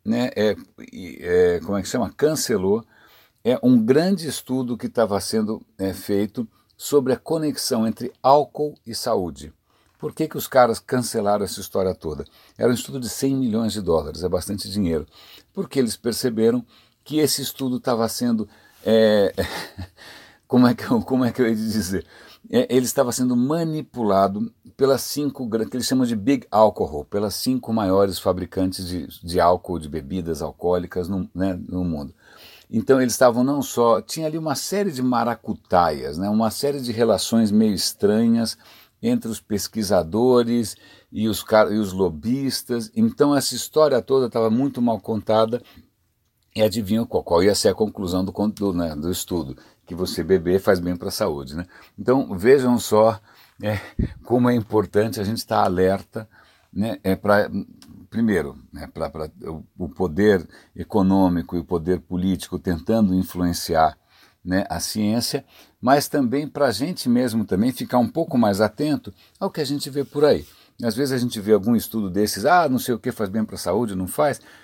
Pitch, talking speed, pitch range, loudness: 110 Hz, 175 wpm, 95-130 Hz, -22 LUFS